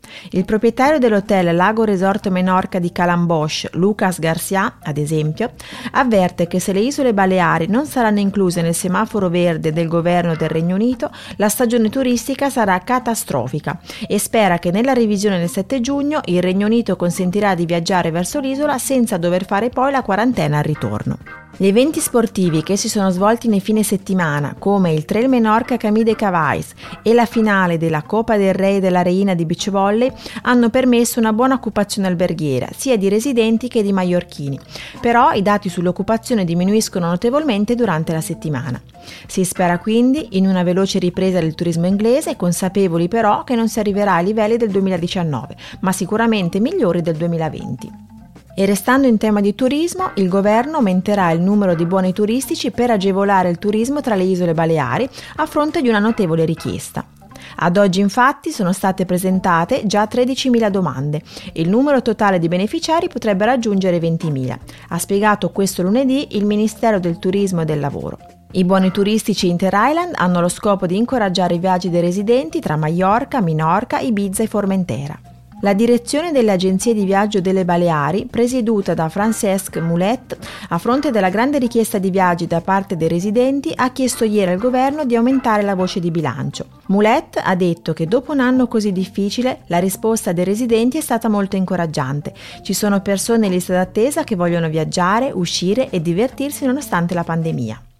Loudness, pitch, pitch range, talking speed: -17 LUFS, 195 Hz, 175-230 Hz, 170 wpm